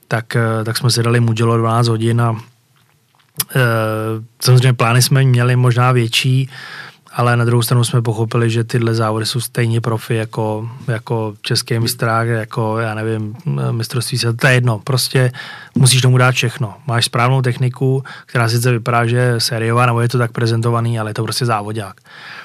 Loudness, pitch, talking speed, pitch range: -15 LUFS, 120 Hz, 175 wpm, 115-125 Hz